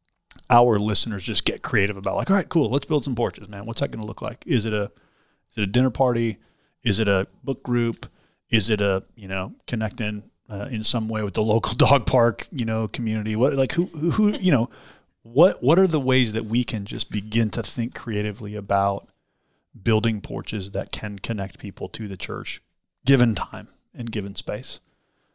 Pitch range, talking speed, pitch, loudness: 105-125 Hz, 205 wpm, 110 Hz, -23 LUFS